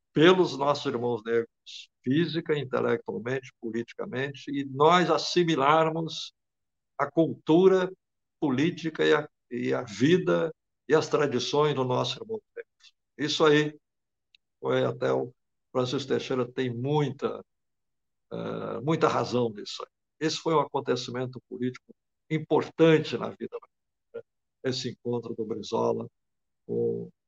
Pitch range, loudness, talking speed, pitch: 125-160 Hz, -27 LUFS, 110 wpm, 145 Hz